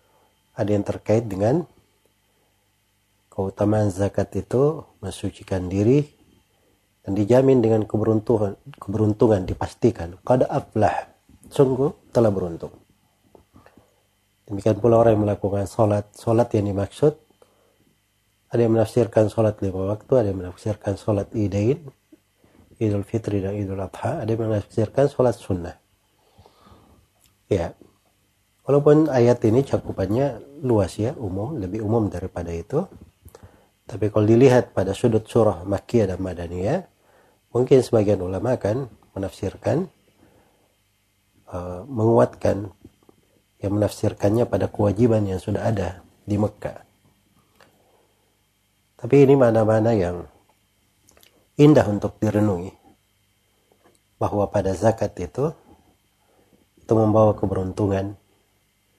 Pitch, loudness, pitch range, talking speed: 105 Hz, -21 LUFS, 100-115 Hz, 105 wpm